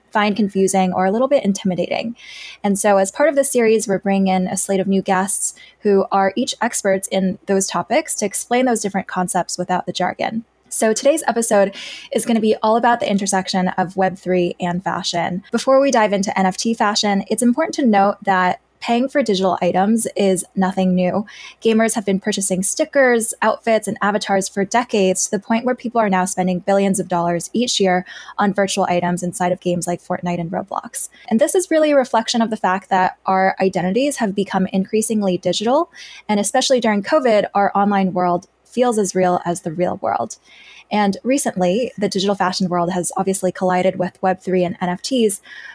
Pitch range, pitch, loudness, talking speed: 185-230 Hz, 195 Hz, -18 LUFS, 195 wpm